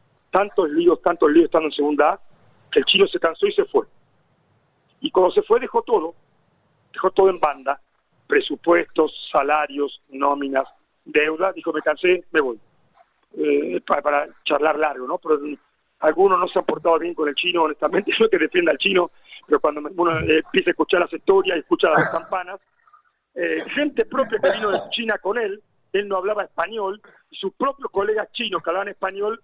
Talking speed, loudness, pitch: 185 wpm, -20 LUFS, 190 Hz